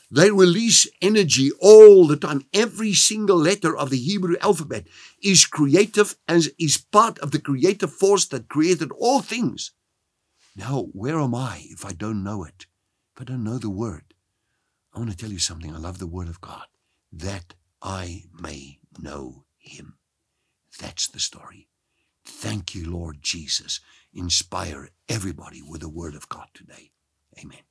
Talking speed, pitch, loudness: 160 wpm, 130 Hz, -18 LUFS